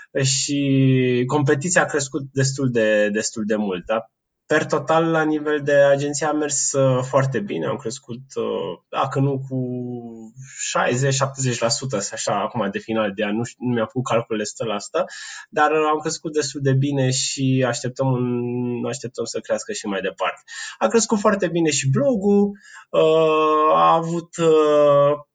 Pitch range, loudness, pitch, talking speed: 125-155 Hz, -20 LUFS, 135 Hz, 150 wpm